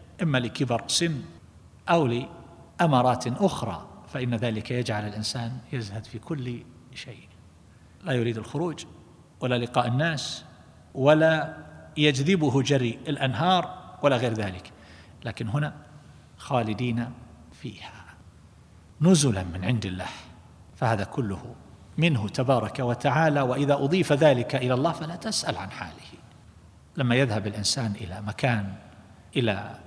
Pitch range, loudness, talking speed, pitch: 115-145 Hz, -26 LUFS, 110 wpm, 125 Hz